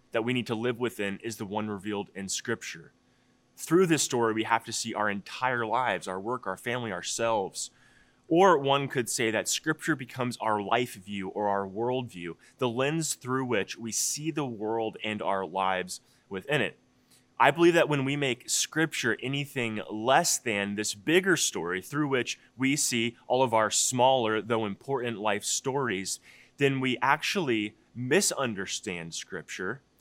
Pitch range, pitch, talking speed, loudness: 105-130 Hz, 115 Hz, 165 wpm, -28 LUFS